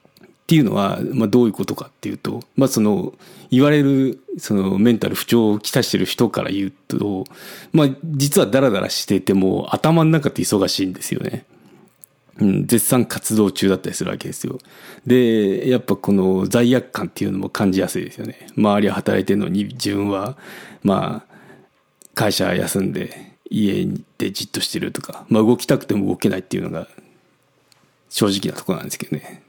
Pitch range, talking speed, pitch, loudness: 100-135 Hz, 350 characters per minute, 110 Hz, -19 LUFS